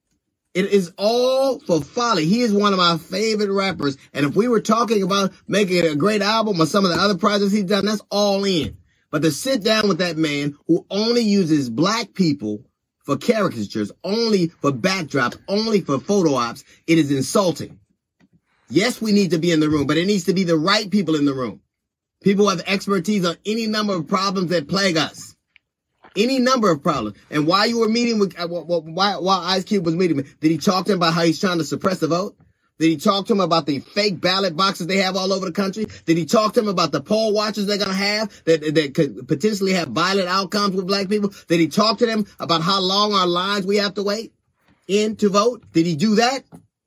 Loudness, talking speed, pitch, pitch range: -19 LUFS, 225 wpm, 195 Hz, 165-205 Hz